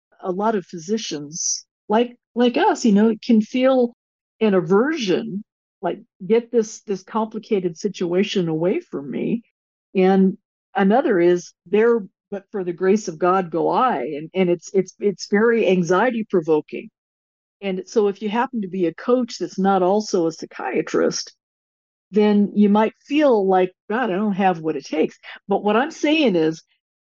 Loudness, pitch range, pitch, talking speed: -20 LUFS, 180-225 Hz, 200 Hz, 160 wpm